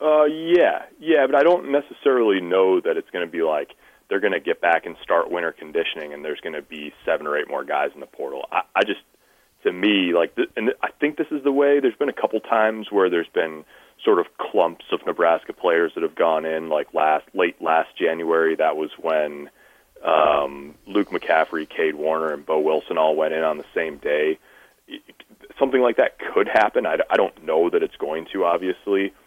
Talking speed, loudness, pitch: 210 wpm, -21 LUFS, 145 Hz